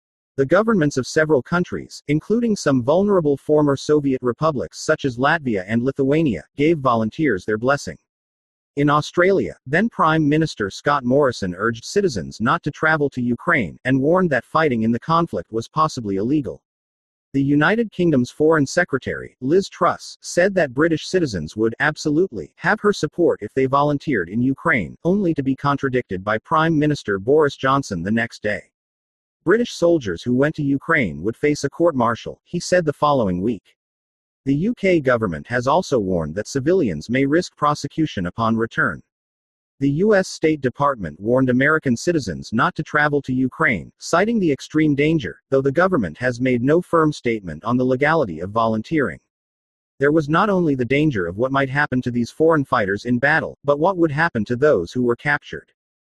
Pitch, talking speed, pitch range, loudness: 140 Hz, 170 wpm, 115-160 Hz, -19 LUFS